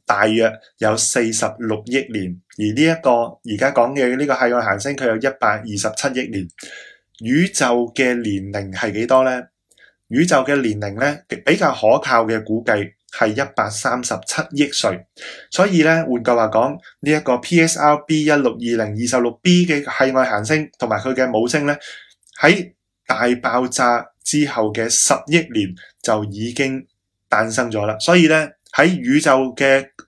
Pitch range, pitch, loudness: 110-145 Hz, 125 Hz, -17 LUFS